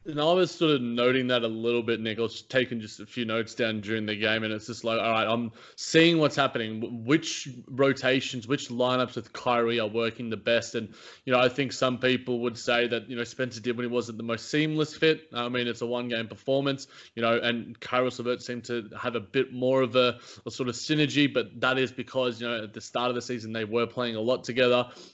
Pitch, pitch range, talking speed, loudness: 120 Hz, 115-130 Hz, 250 wpm, -27 LUFS